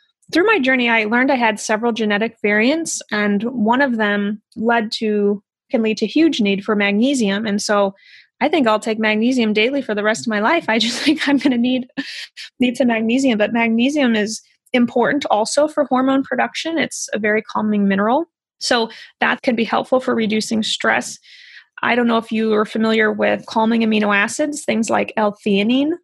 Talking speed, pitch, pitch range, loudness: 185 wpm, 230 Hz, 215-265 Hz, -17 LUFS